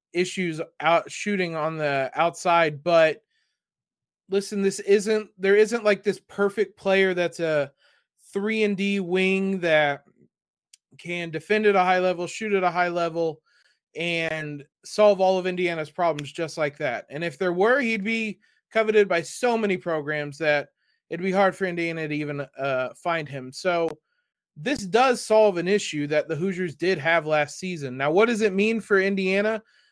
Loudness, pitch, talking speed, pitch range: -24 LUFS, 180 Hz, 170 wpm, 160-205 Hz